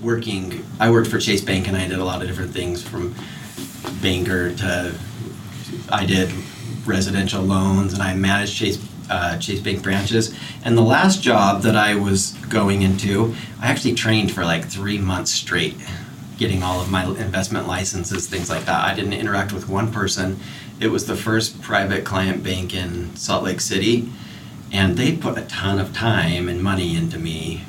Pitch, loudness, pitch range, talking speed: 100 Hz, -20 LUFS, 95-110 Hz, 180 wpm